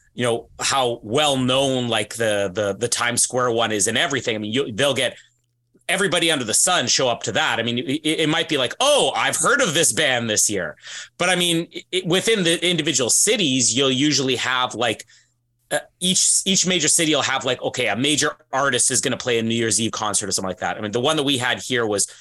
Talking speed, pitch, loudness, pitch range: 240 wpm, 130 Hz, -19 LUFS, 115-155 Hz